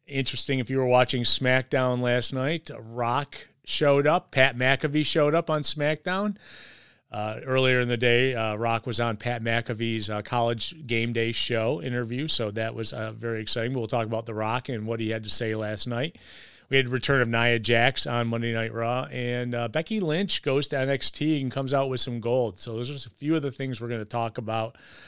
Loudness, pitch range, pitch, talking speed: -26 LUFS, 115-135 Hz, 125 Hz, 220 wpm